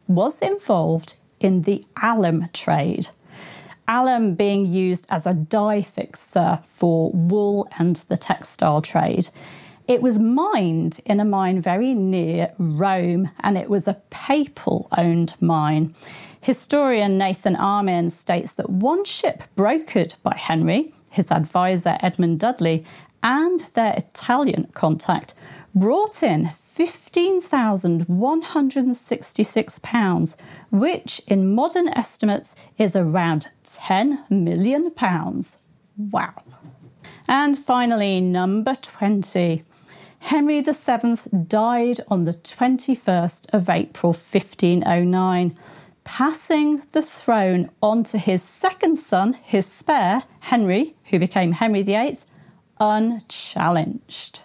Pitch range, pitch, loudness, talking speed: 175-240 Hz, 200 Hz, -21 LUFS, 105 wpm